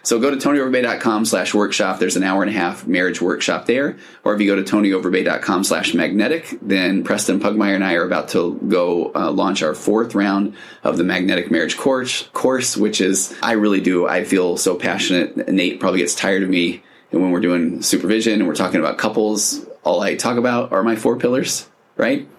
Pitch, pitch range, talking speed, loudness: 100 Hz, 95-110 Hz, 205 wpm, -18 LUFS